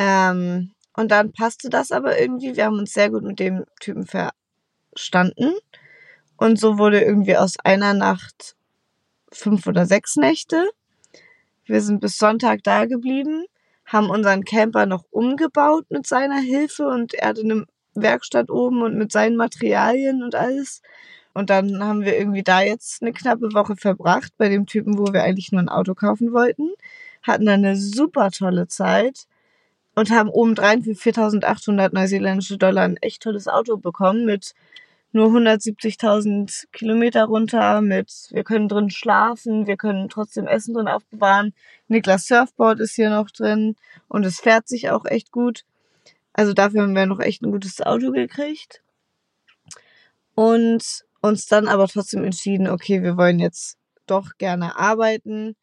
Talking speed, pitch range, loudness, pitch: 155 wpm, 195-235 Hz, -19 LUFS, 215 Hz